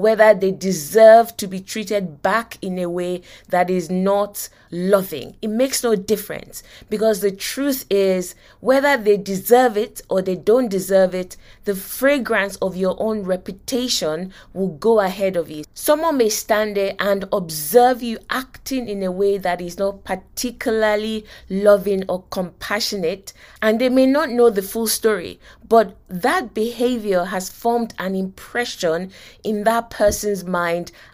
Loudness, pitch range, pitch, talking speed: -19 LUFS, 185-225 Hz, 205 Hz, 150 wpm